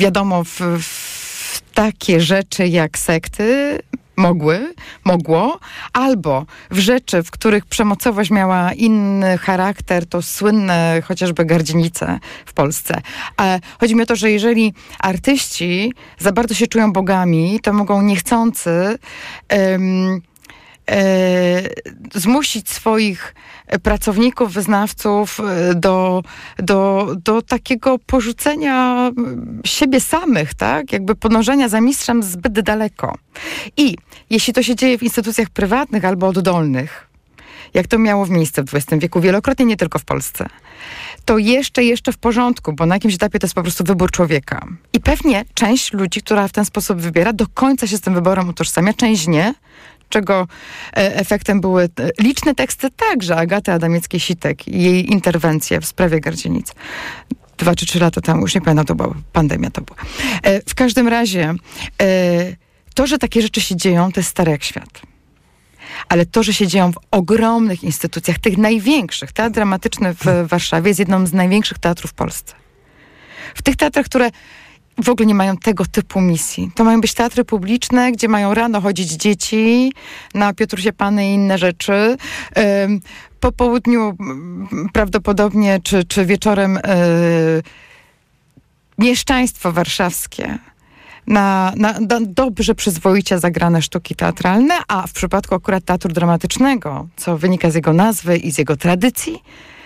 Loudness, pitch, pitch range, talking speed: -16 LUFS, 200 Hz, 180-230 Hz, 140 wpm